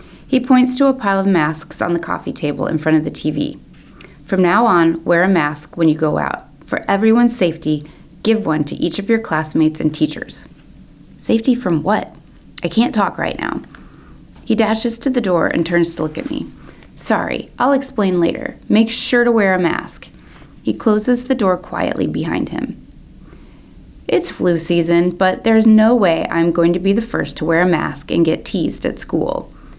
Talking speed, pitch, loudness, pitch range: 195 wpm, 180 Hz, -16 LUFS, 165-225 Hz